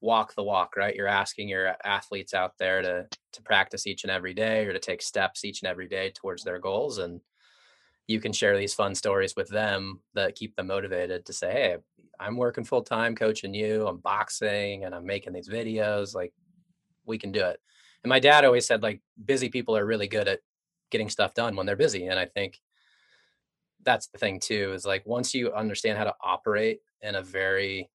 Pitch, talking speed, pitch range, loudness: 110 Hz, 210 wpm, 100-135 Hz, -27 LUFS